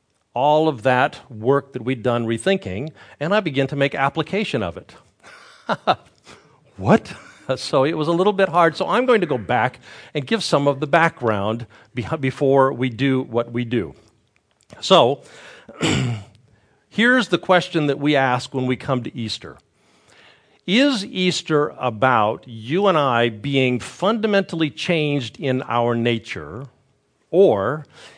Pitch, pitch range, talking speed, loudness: 135 Hz, 120-160 Hz, 145 wpm, -20 LUFS